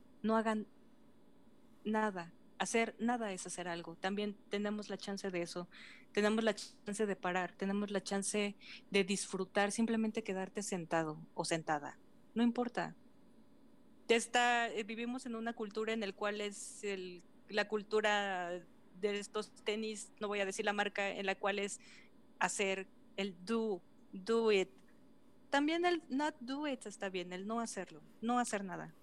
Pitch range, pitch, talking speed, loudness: 195-245 Hz, 215 Hz, 155 wpm, -38 LUFS